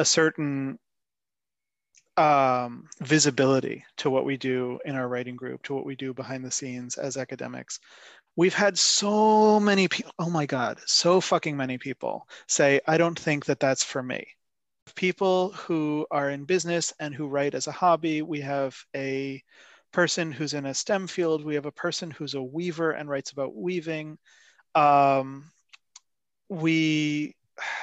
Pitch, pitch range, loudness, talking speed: 150 Hz, 135-170 Hz, -25 LUFS, 160 wpm